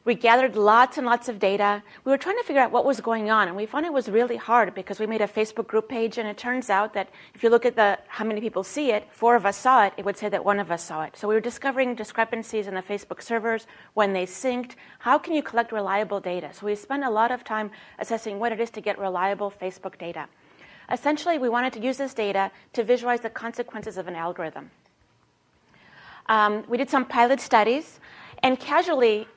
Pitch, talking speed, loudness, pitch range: 220 Hz, 235 wpm, -24 LUFS, 205-245 Hz